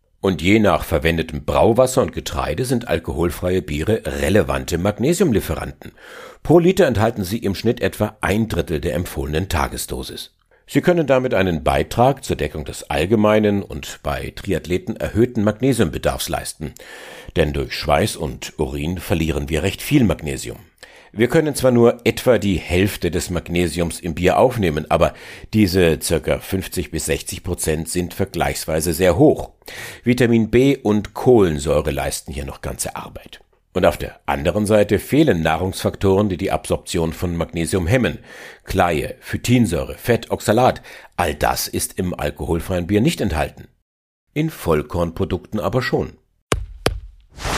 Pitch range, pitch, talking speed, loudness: 85-110 Hz, 95 Hz, 140 wpm, -19 LUFS